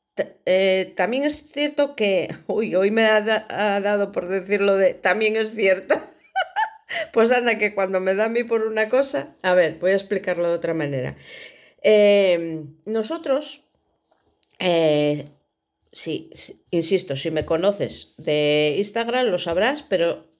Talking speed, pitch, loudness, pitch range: 150 wpm, 200 Hz, -21 LUFS, 180-230 Hz